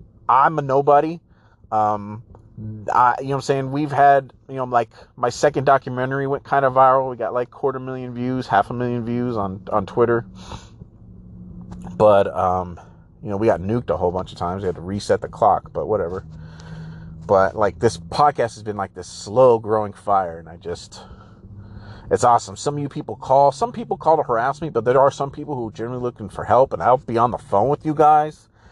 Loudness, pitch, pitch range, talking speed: -20 LUFS, 115 Hz, 100-135 Hz, 215 wpm